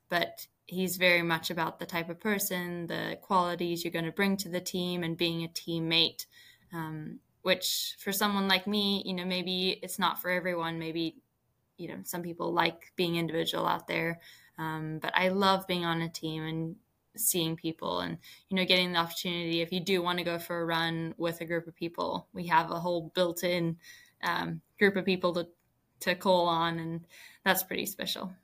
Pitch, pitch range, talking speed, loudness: 175 Hz, 165-185 Hz, 200 wpm, -31 LUFS